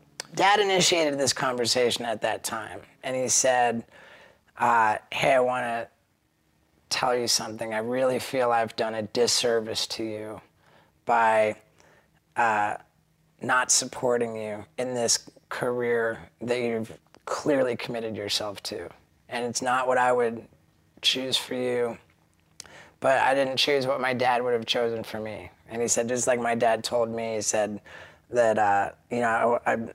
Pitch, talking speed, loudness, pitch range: 120 Hz, 160 wpm, -25 LUFS, 110-125 Hz